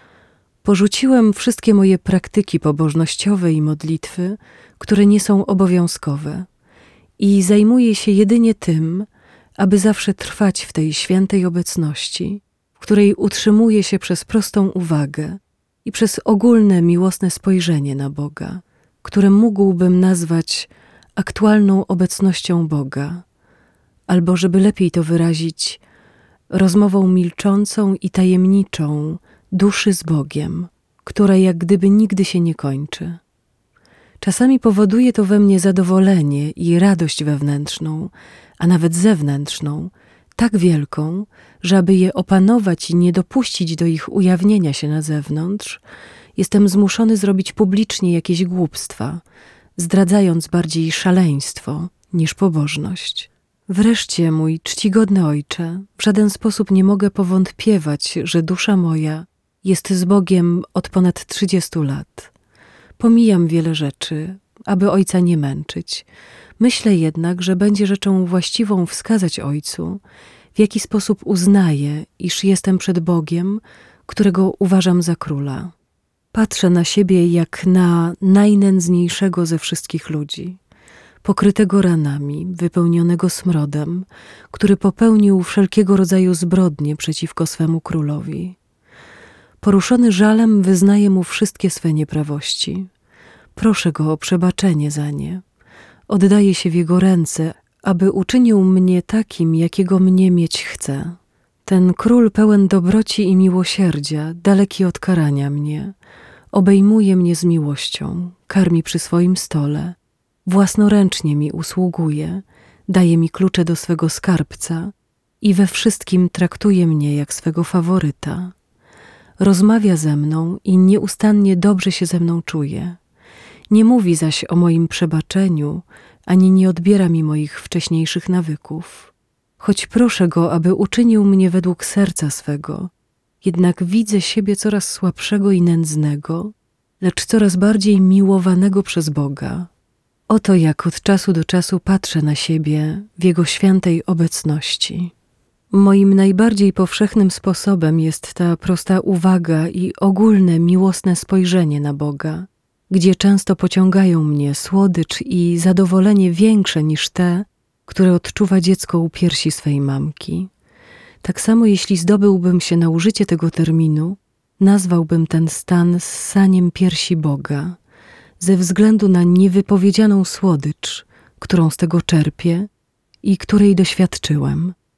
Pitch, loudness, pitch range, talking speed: 185 Hz, -15 LUFS, 165-195 Hz, 120 wpm